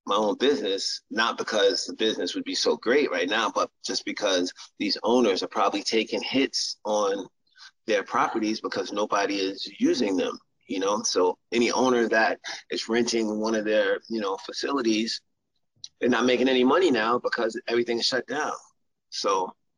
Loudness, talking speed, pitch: -25 LUFS, 170 wpm, 120 Hz